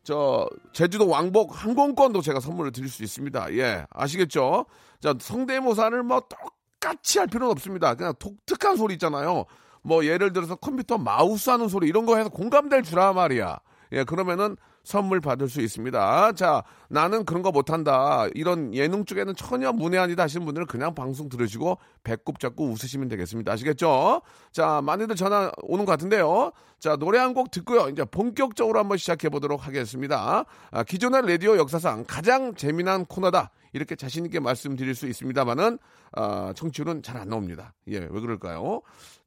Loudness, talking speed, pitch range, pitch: -25 LUFS, 375 characters per minute, 135-220 Hz, 175 Hz